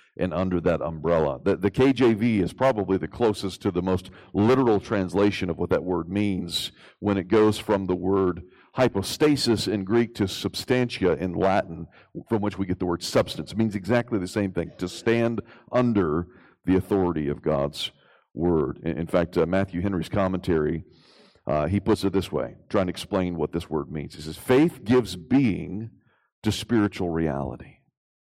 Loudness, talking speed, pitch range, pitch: -25 LUFS, 175 wpm, 85-110 Hz, 95 Hz